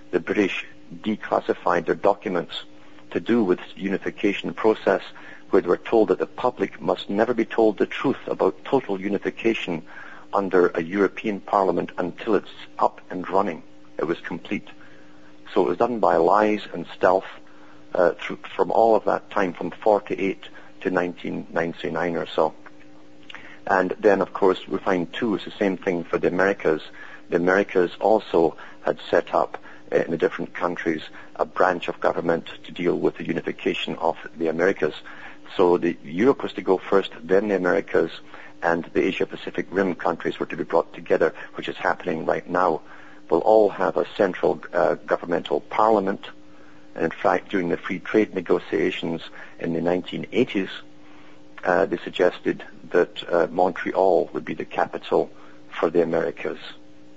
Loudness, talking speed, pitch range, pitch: -23 LUFS, 160 wpm, 60-100 Hz, 85 Hz